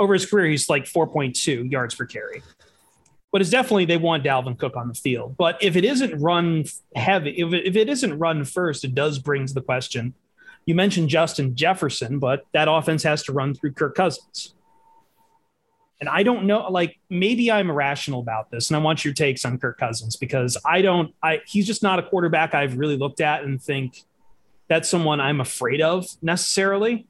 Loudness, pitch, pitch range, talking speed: -22 LUFS, 160 Hz, 140-195 Hz, 200 wpm